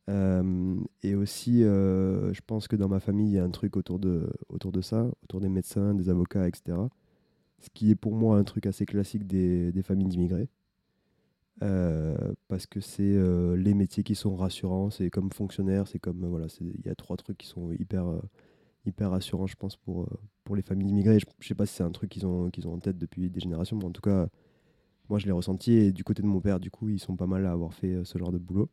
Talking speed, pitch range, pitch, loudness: 245 wpm, 90-100 Hz, 95 Hz, -29 LUFS